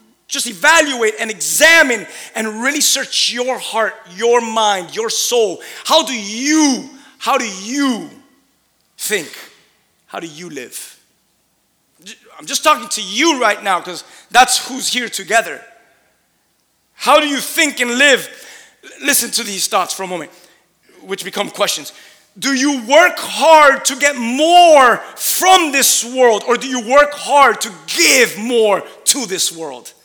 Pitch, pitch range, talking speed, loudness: 245 Hz, 220-285 Hz, 145 wpm, -13 LUFS